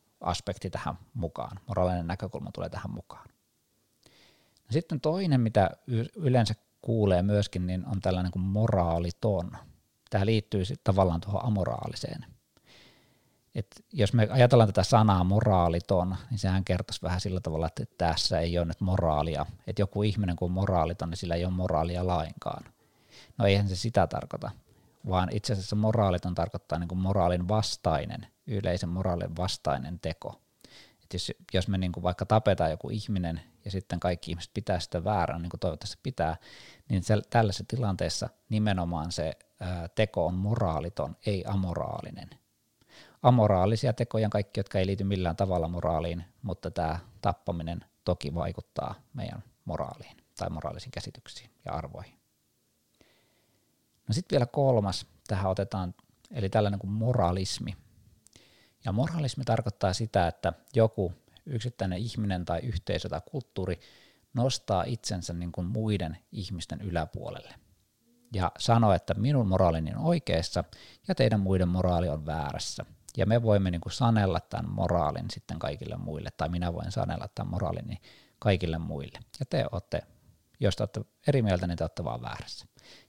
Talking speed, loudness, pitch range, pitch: 145 wpm, -30 LUFS, 90-110 Hz, 95 Hz